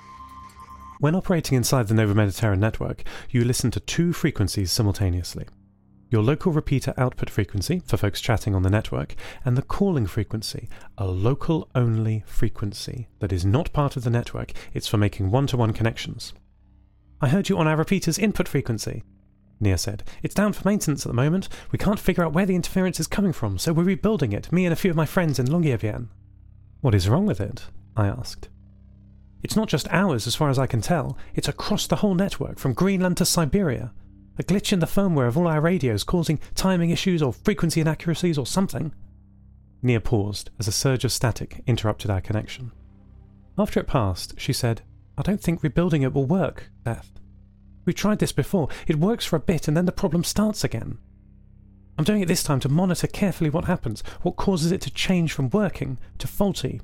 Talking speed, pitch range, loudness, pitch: 195 wpm, 105-170 Hz, -24 LUFS, 130 Hz